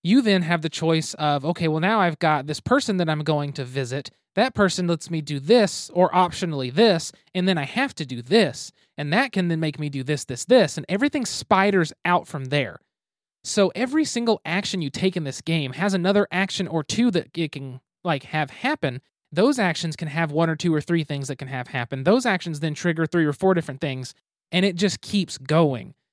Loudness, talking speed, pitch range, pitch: -23 LUFS, 225 wpm, 150-195 Hz, 165 Hz